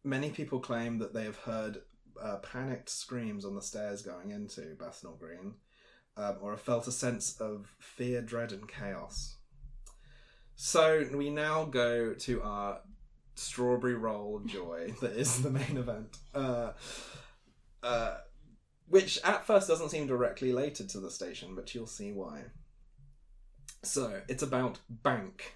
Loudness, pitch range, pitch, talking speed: -34 LUFS, 110-140 Hz, 125 Hz, 145 wpm